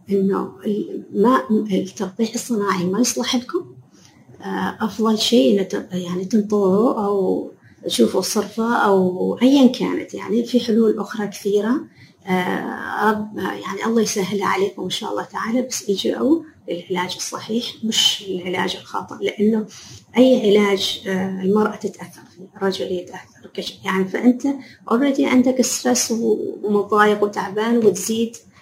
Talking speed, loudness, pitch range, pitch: 110 wpm, -19 LUFS, 195-235 Hz, 210 Hz